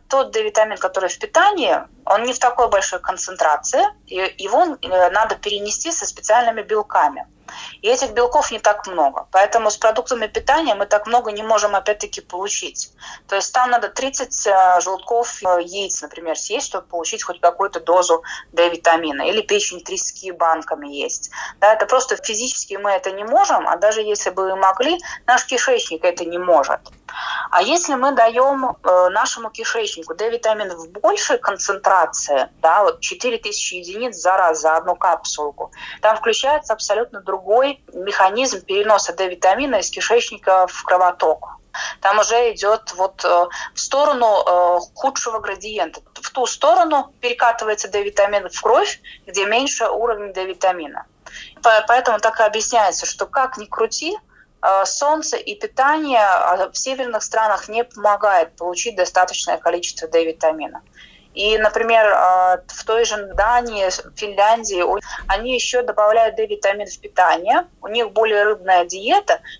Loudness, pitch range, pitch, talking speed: -18 LUFS, 190-250 Hz, 215 Hz, 140 wpm